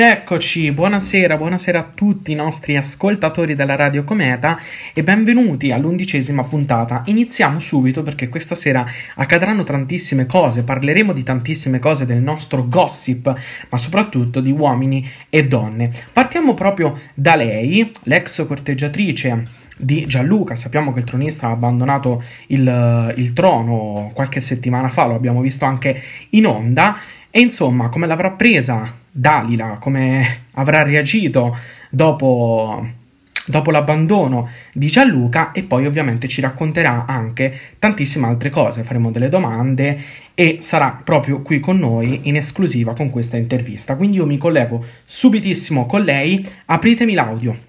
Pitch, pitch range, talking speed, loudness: 140 Hz, 125-165 Hz, 135 wpm, -16 LUFS